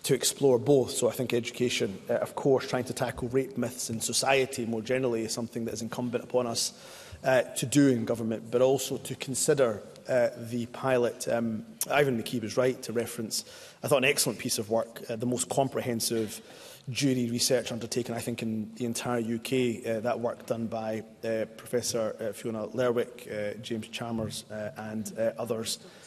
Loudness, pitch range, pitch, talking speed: -29 LUFS, 115-125 Hz, 120 Hz, 185 wpm